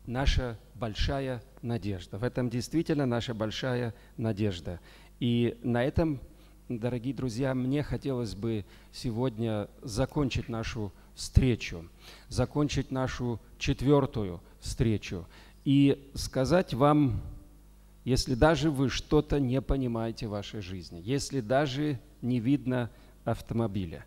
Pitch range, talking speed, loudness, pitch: 110-135 Hz, 105 wpm, -30 LUFS, 125 Hz